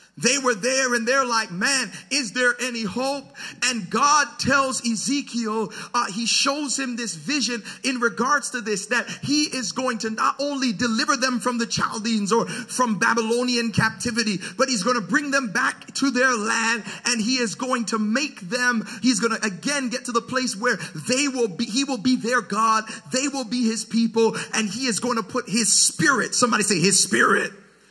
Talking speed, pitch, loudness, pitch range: 200 wpm, 240 Hz, -22 LUFS, 225-255 Hz